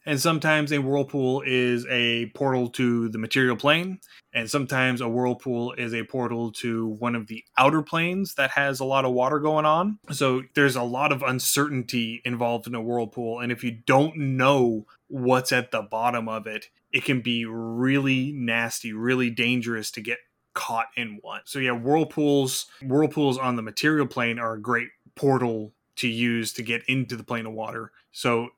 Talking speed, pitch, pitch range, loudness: 185 wpm, 125 Hz, 115-140 Hz, -24 LUFS